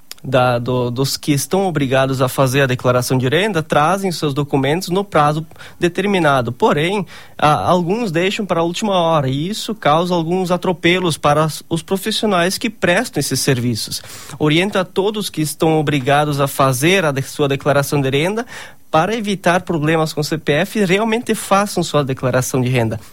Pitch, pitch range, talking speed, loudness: 155 Hz, 140-185 Hz, 165 wpm, -16 LUFS